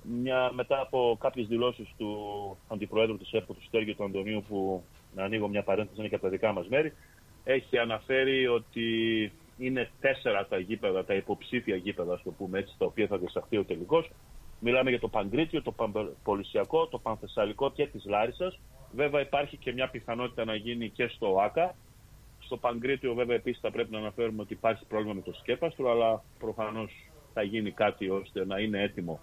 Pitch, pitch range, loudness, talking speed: 115 Hz, 105-130 Hz, -31 LUFS, 180 wpm